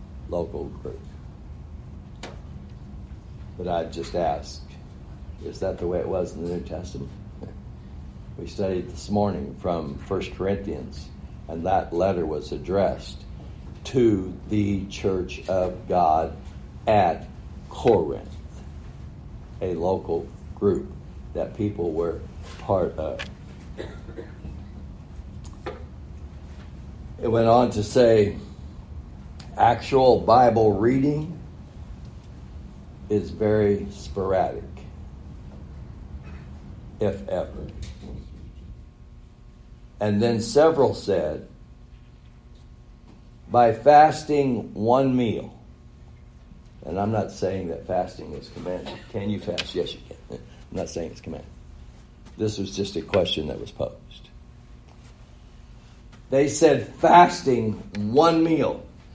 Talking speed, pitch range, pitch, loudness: 95 wpm, 70-105 Hz, 85 Hz, -23 LUFS